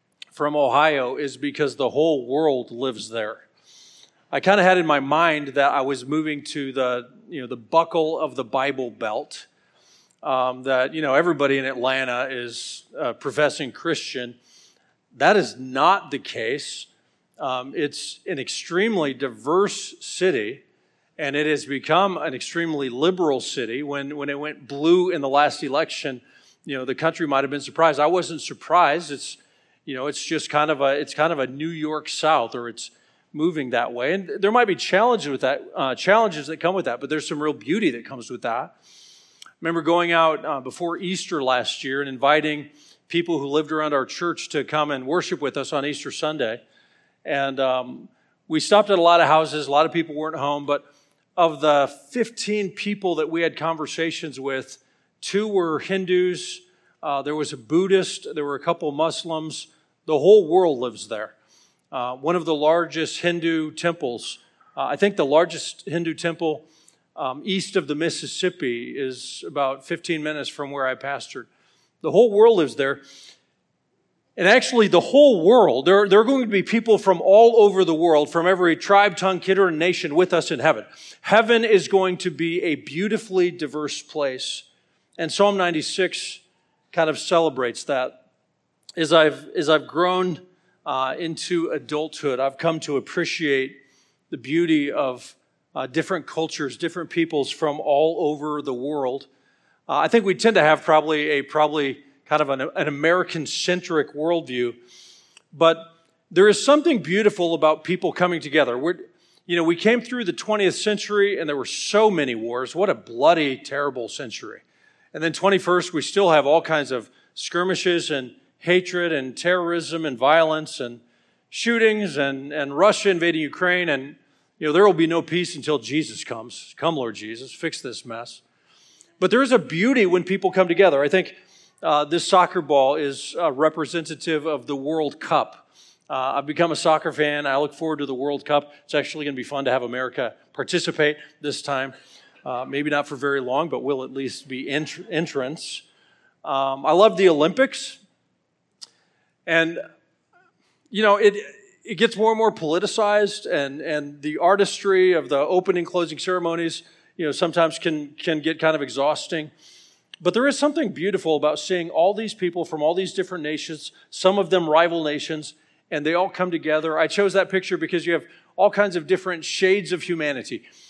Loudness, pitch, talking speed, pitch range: -21 LUFS, 160 Hz, 180 wpm, 145-180 Hz